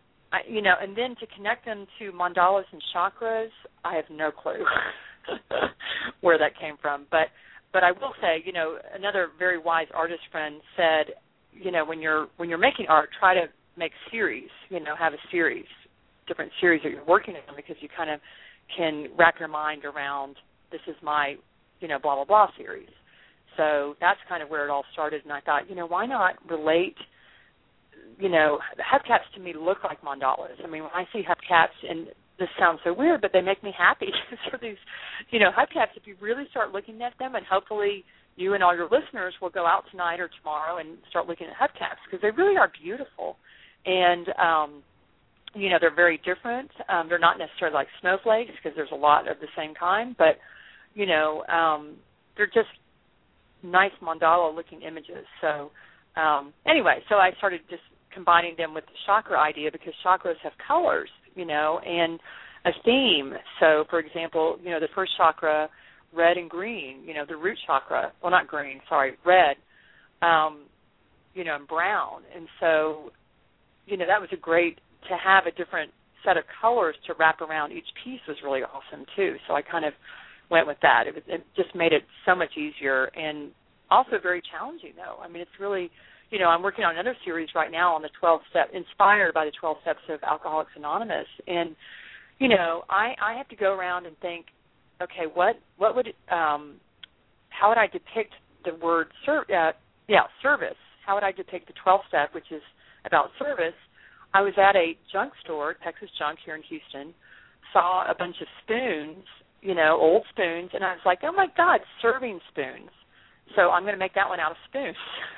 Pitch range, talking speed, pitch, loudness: 155-195 Hz, 190 wpm, 170 Hz, -25 LUFS